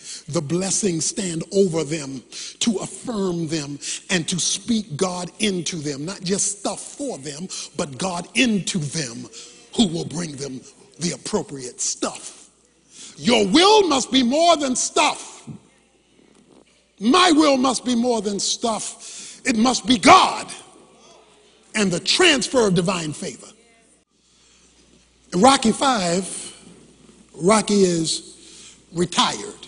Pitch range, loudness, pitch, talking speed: 175-245 Hz, -20 LUFS, 195 Hz, 120 wpm